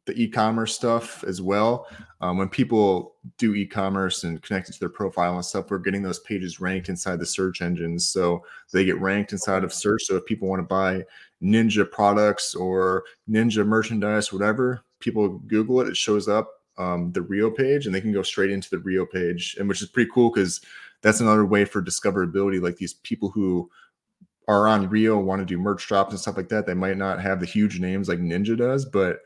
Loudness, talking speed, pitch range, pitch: -23 LUFS, 210 wpm, 95-110 Hz, 100 Hz